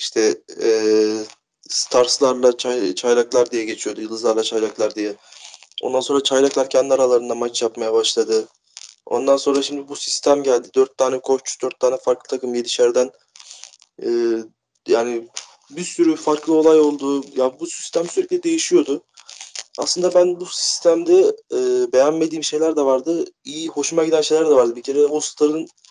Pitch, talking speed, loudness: 150 Hz, 145 wpm, -19 LUFS